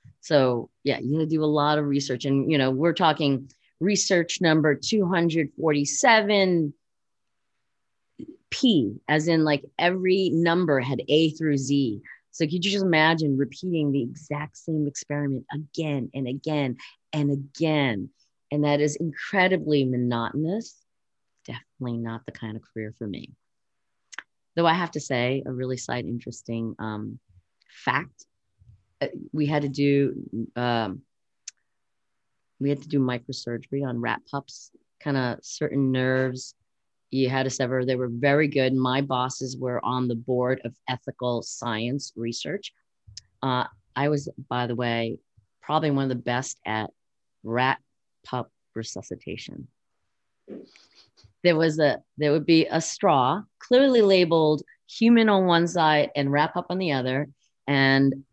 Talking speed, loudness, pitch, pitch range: 140 wpm, -24 LUFS, 140 Hz, 120-155 Hz